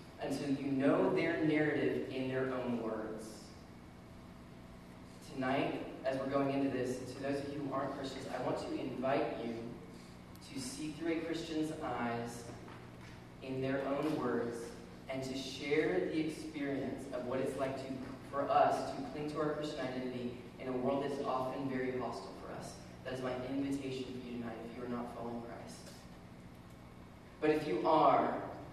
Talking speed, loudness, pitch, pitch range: 170 wpm, -37 LUFS, 130 Hz, 85-140 Hz